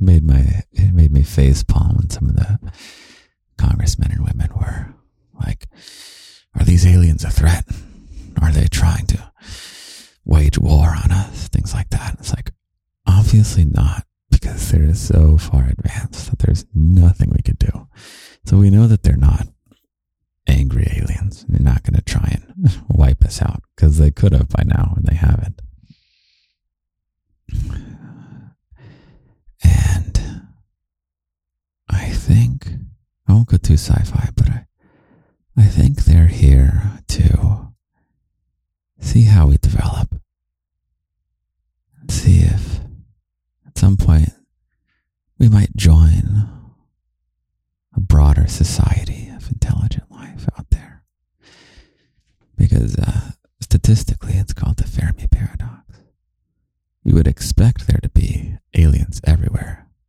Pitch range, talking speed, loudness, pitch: 80-100 Hz, 125 wpm, -16 LUFS, 90 Hz